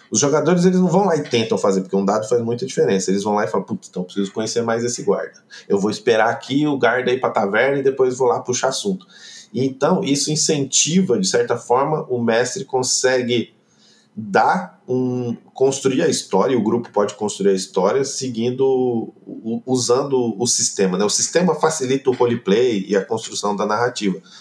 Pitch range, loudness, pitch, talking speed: 110-135 Hz, -19 LUFS, 125 Hz, 195 wpm